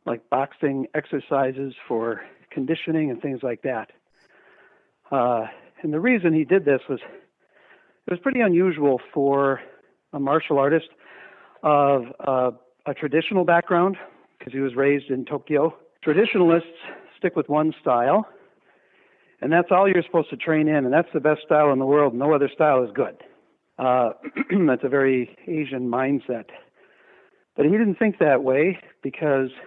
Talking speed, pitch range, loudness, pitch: 150 wpm, 135-170 Hz, -22 LUFS, 150 Hz